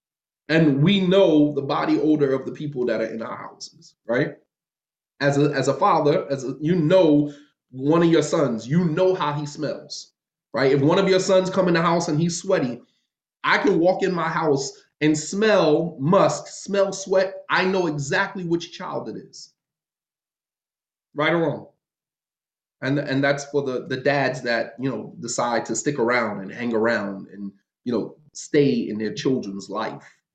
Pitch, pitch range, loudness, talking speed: 150 Hz, 135-175 Hz, -22 LUFS, 180 wpm